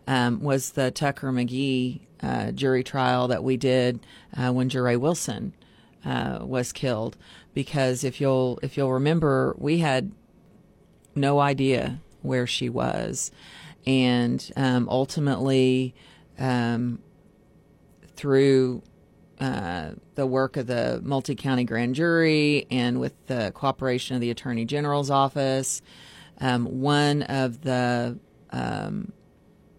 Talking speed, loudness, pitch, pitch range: 125 wpm, -25 LUFS, 130 Hz, 125-140 Hz